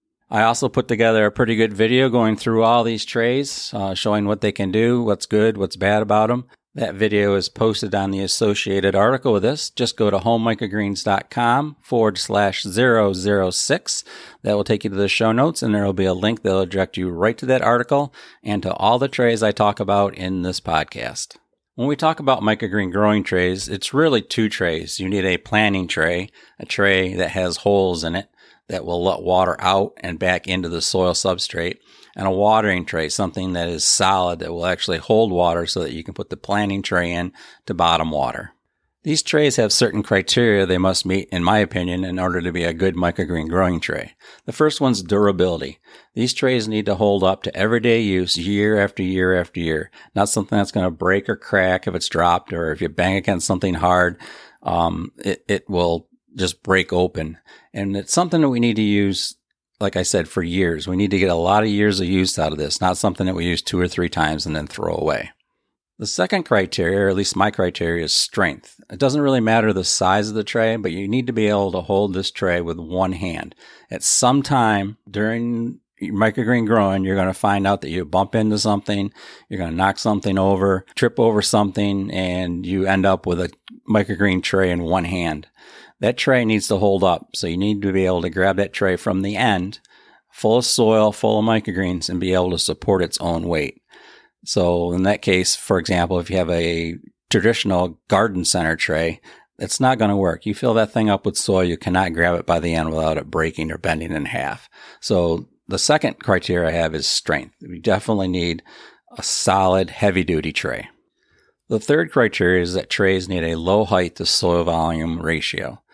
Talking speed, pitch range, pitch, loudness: 210 wpm, 90-110 Hz, 95 Hz, -19 LUFS